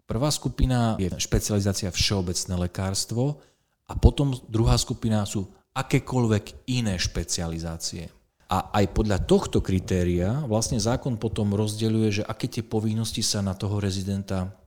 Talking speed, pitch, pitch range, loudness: 125 wpm, 105 Hz, 95-115 Hz, -26 LUFS